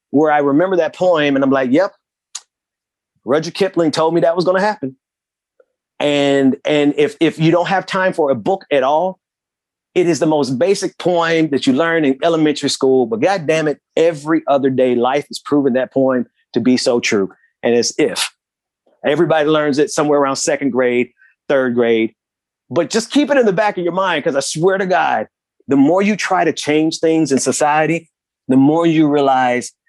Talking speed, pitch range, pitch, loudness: 195 wpm, 135-170 Hz, 150 Hz, -15 LUFS